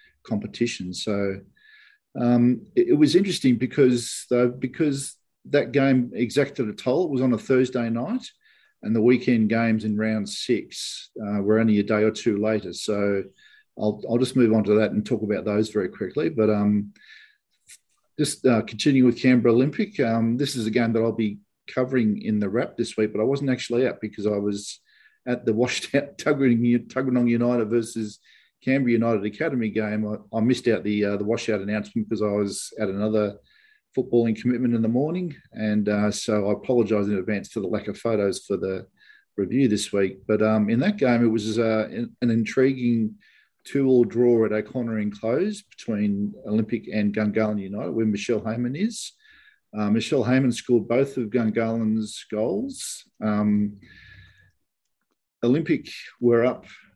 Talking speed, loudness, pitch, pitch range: 175 wpm, -23 LUFS, 115 Hz, 105-130 Hz